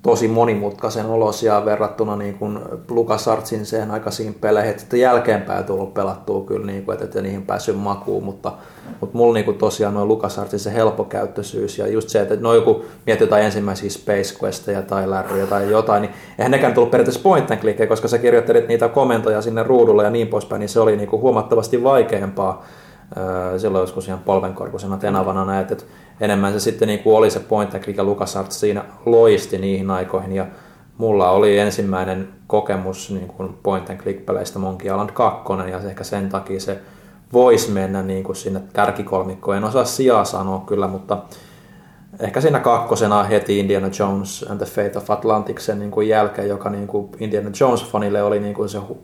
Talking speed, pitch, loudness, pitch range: 170 wpm, 105 Hz, -19 LUFS, 95-110 Hz